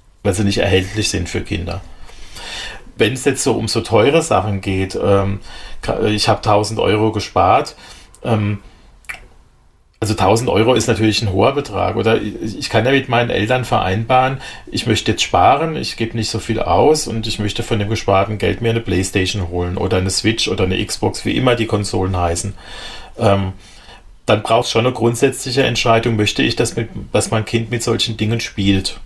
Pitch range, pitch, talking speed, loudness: 95-115 Hz, 110 Hz, 190 wpm, -16 LUFS